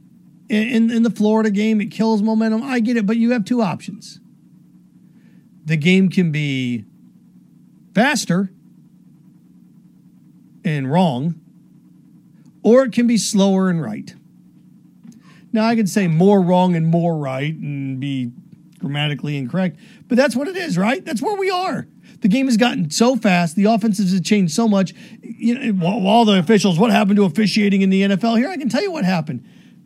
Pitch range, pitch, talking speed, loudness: 175-225 Hz, 200 Hz, 170 wpm, -17 LUFS